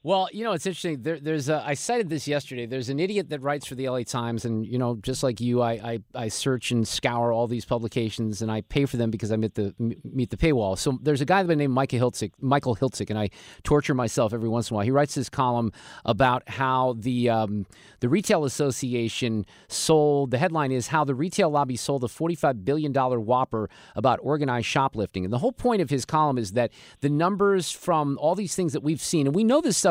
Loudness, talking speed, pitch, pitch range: -25 LUFS, 240 wpm, 130 Hz, 115-150 Hz